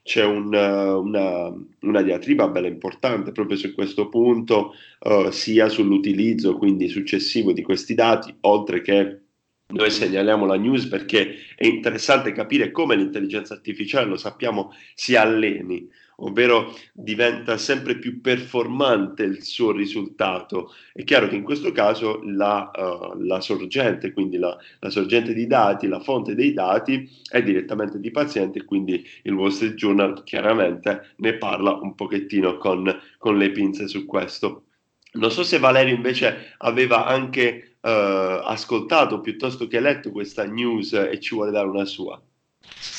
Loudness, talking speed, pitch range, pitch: -21 LUFS, 145 wpm, 100-130 Hz, 110 Hz